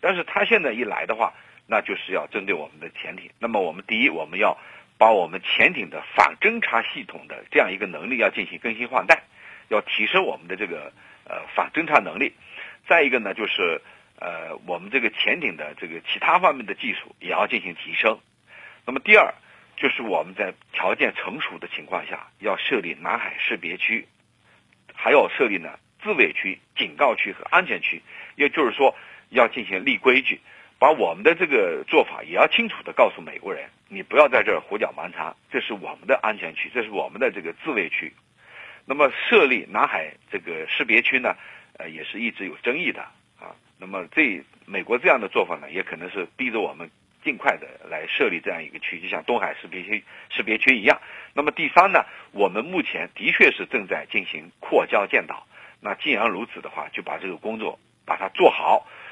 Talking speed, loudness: 300 characters per minute, -22 LUFS